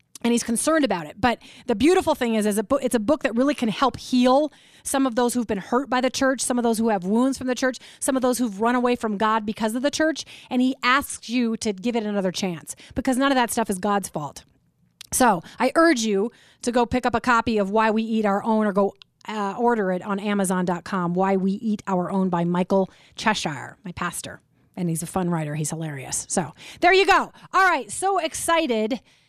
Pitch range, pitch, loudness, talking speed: 195-255 Hz, 225 Hz, -22 LUFS, 240 wpm